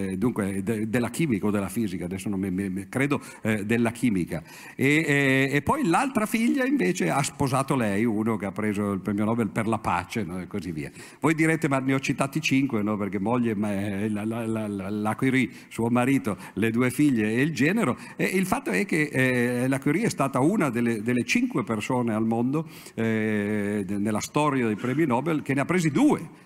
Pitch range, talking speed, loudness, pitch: 105-140 Hz, 200 wpm, -25 LUFS, 120 Hz